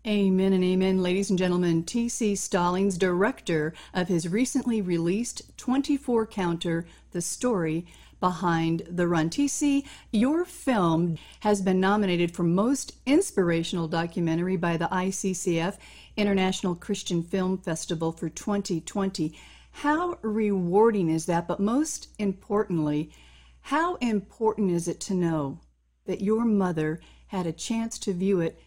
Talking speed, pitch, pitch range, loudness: 130 wpm, 190 Hz, 170-215 Hz, -26 LUFS